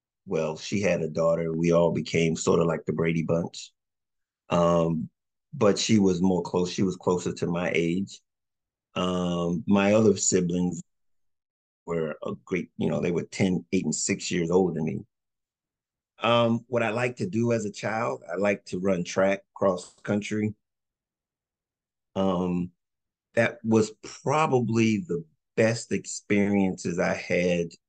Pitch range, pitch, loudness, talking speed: 85-105 Hz, 95 Hz, -26 LUFS, 150 wpm